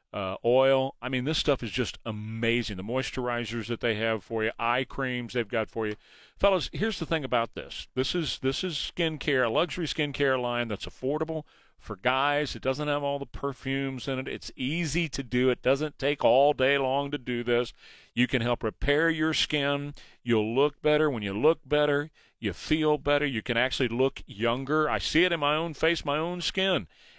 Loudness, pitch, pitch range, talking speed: -28 LUFS, 135 Hz, 120-150 Hz, 210 wpm